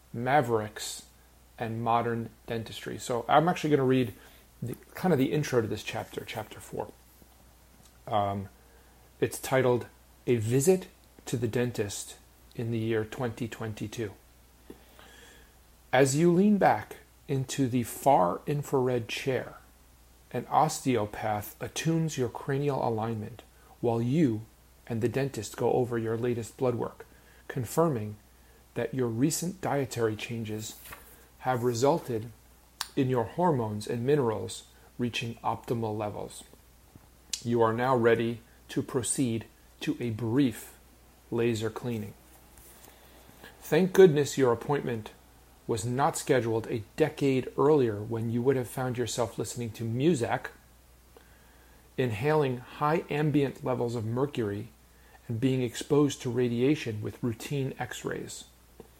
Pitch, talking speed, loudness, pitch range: 115 Hz, 120 wpm, -29 LUFS, 100-130 Hz